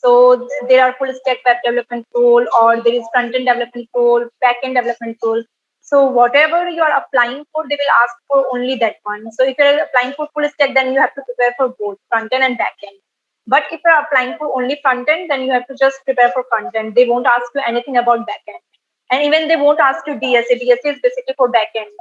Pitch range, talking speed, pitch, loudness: 240-285 Hz, 250 wpm, 255 Hz, -15 LUFS